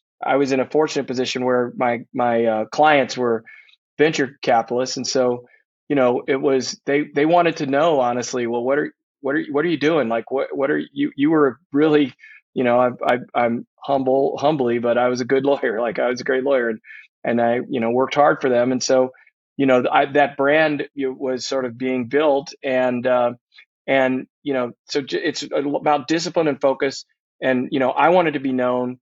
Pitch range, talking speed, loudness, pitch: 125-145 Hz, 215 wpm, -20 LUFS, 130 Hz